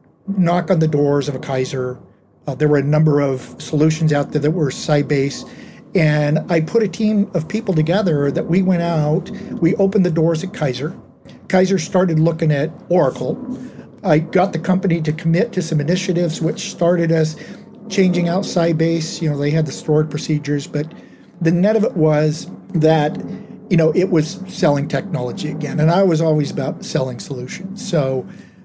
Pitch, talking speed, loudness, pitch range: 165 Hz, 180 wpm, -18 LUFS, 150-185 Hz